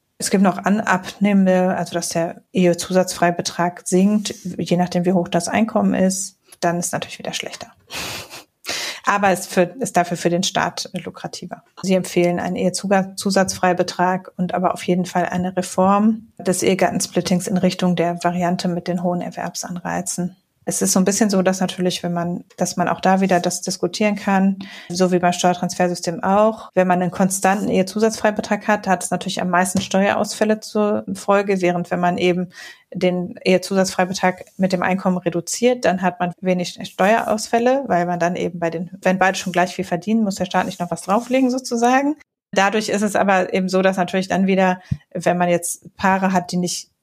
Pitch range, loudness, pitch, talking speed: 175-200 Hz, -19 LUFS, 185 Hz, 180 wpm